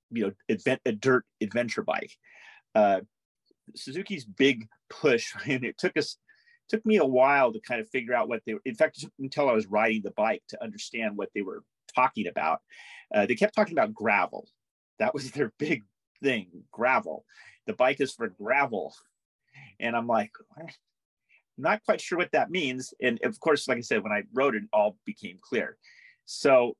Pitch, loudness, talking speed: 140 Hz, -28 LUFS, 185 wpm